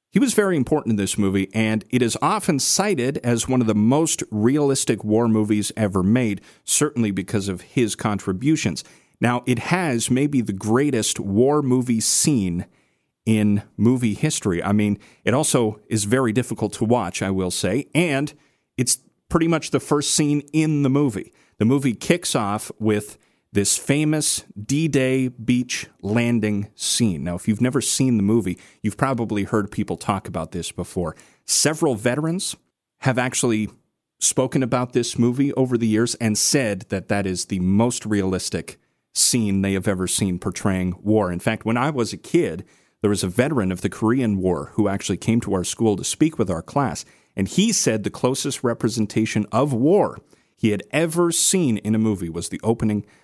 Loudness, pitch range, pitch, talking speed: -21 LUFS, 105-130 Hz, 110 Hz, 180 wpm